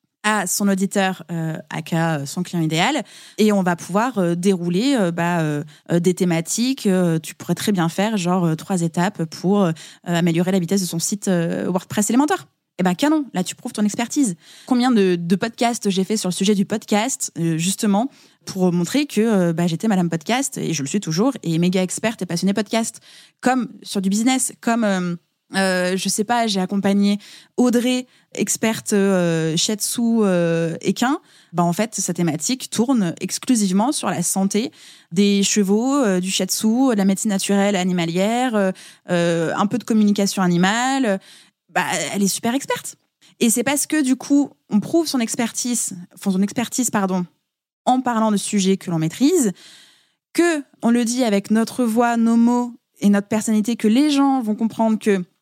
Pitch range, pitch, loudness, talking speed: 180-235 Hz, 200 Hz, -20 LUFS, 185 wpm